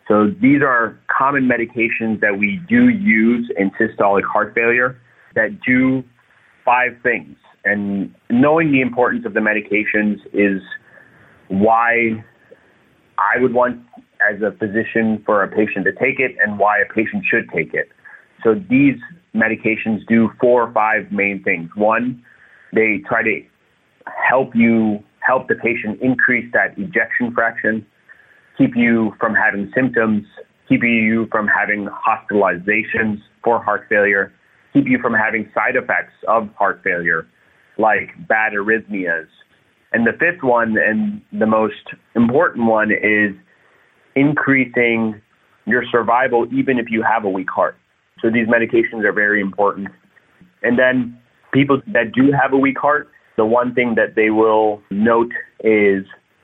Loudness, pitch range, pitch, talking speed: -16 LUFS, 105-125 Hz, 115 Hz, 145 wpm